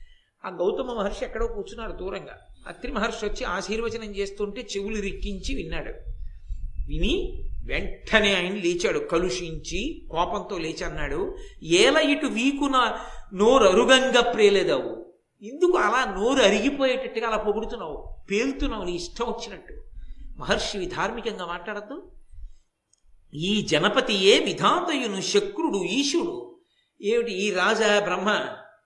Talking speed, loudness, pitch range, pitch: 105 wpm, -24 LUFS, 195-275 Hz, 220 Hz